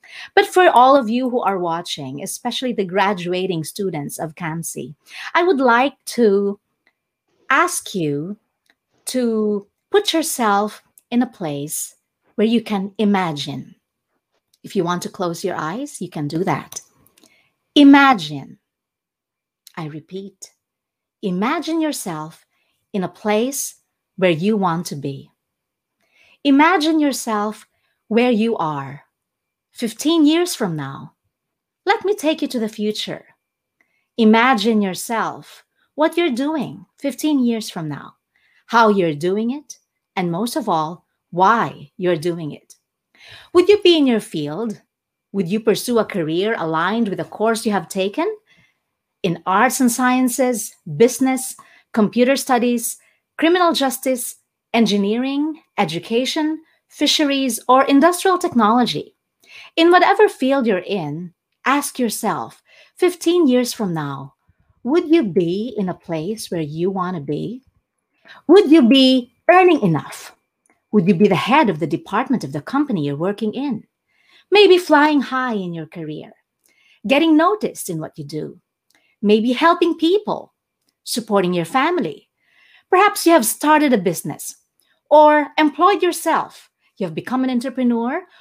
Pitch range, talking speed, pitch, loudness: 185-290 Hz, 135 wpm, 230 Hz, -18 LUFS